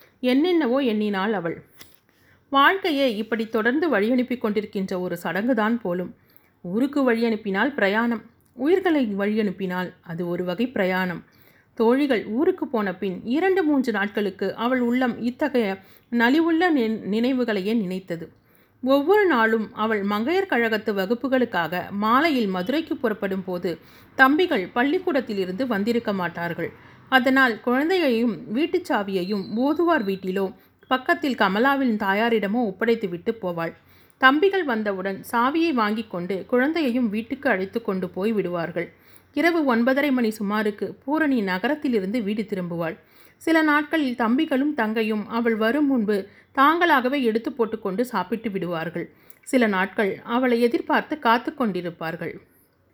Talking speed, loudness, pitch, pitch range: 105 wpm, -23 LUFS, 230 Hz, 195-270 Hz